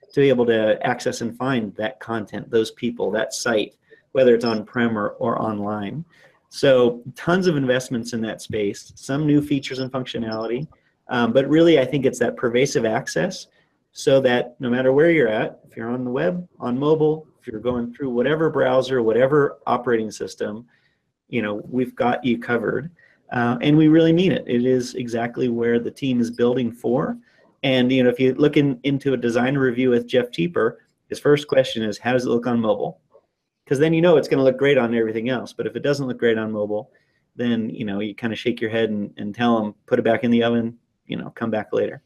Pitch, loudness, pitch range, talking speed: 125 Hz, -21 LUFS, 115-135 Hz, 215 wpm